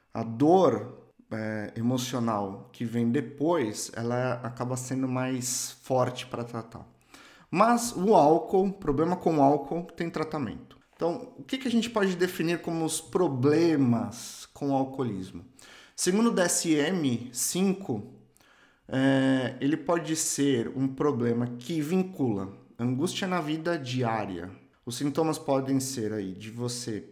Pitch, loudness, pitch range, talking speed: 135 Hz, -28 LUFS, 120-170 Hz, 130 wpm